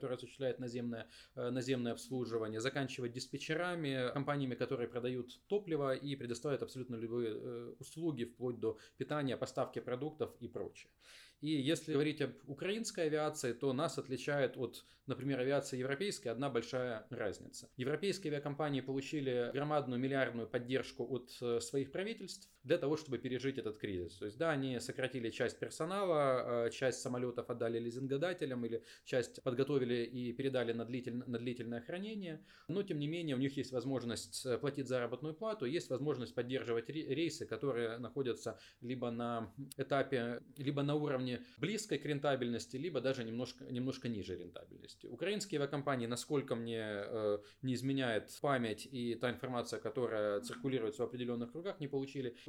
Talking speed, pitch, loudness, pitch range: 140 wpm, 130 Hz, -40 LUFS, 120-145 Hz